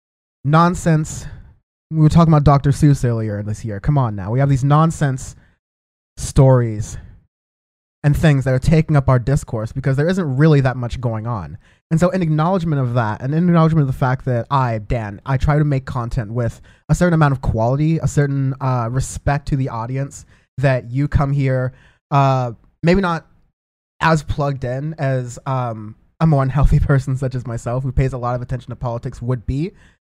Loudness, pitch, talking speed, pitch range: -18 LUFS, 135 Hz, 190 wpm, 120-150 Hz